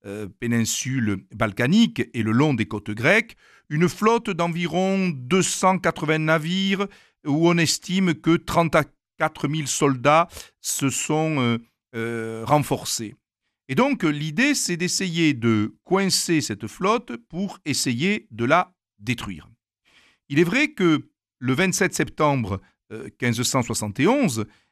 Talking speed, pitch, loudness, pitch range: 120 wpm, 150 Hz, -22 LUFS, 115-180 Hz